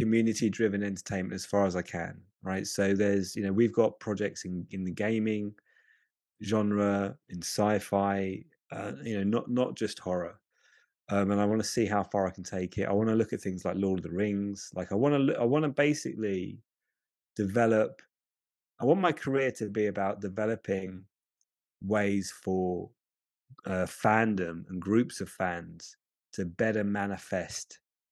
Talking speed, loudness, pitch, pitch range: 175 wpm, -30 LUFS, 100 Hz, 95-110 Hz